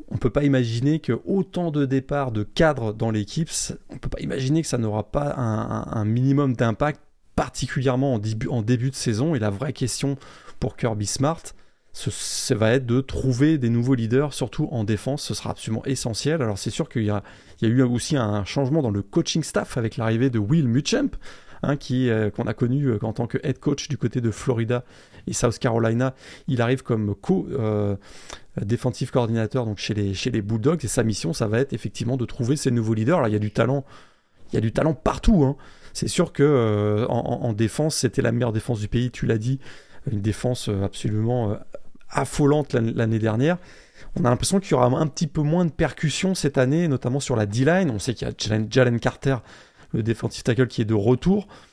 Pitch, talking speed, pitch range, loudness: 125 Hz, 215 wpm, 115-140 Hz, -23 LUFS